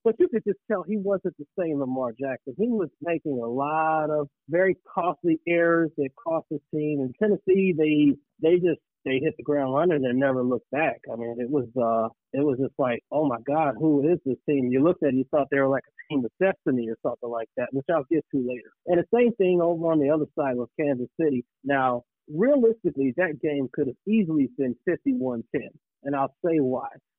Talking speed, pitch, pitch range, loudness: 225 wpm, 150 Hz, 135-170 Hz, -25 LUFS